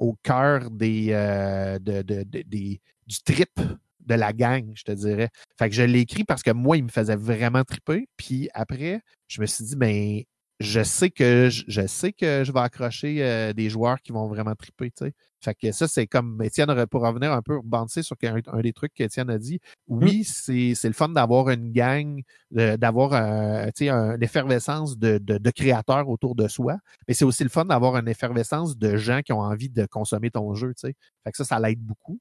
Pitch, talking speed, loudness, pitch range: 120 Hz, 220 wpm, -24 LUFS, 110-135 Hz